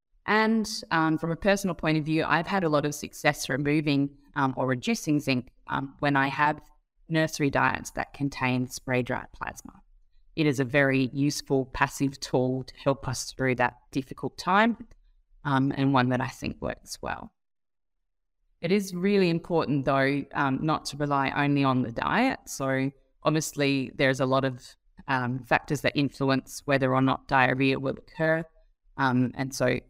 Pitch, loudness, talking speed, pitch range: 140 Hz, -27 LUFS, 165 wpm, 130-155 Hz